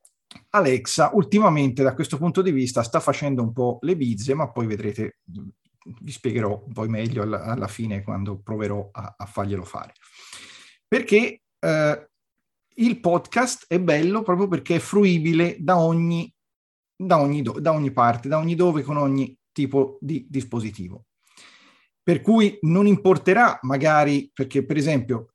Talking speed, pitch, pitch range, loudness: 150 wpm, 145 Hz, 120-175 Hz, -22 LUFS